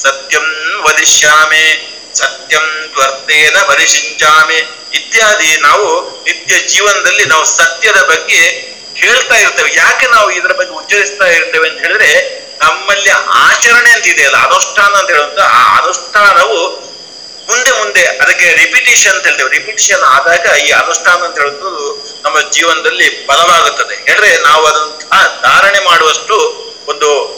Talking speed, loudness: 115 wpm, -7 LUFS